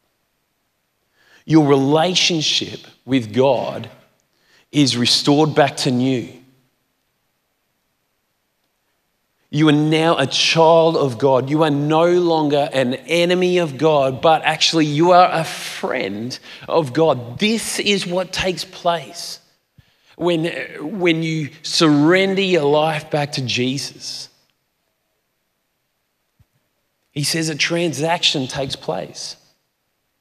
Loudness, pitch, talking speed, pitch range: -17 LUFS, 155 Hz, 105 wpm, 140-170 Hz